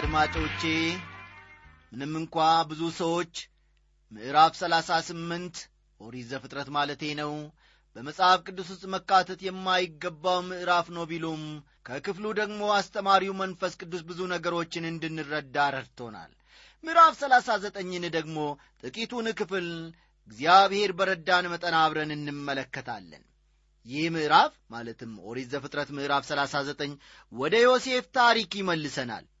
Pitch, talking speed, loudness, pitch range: 165 Hz, 105 wpm, -27 LUFS, 145-190 Hz